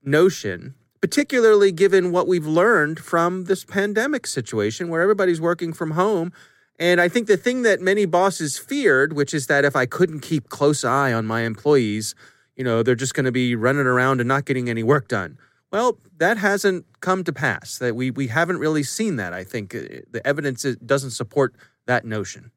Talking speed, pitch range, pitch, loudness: 190 wpm, 125-180 Hz, 145 Hz, -20 LUFS